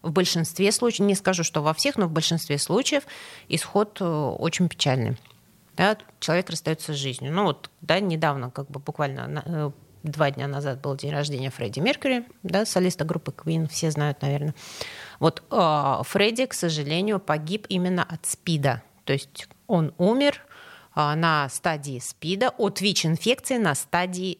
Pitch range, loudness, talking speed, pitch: 145-195 Hz, -25 LUFS, 150 wpm, 165 Hz